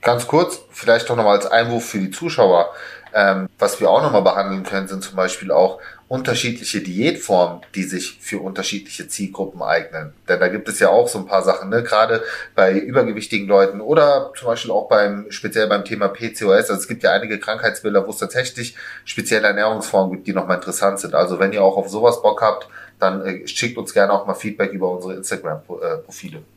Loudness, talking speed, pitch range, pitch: -18 LUFS, 195 wpm, 95-115 Hz, 100 Hz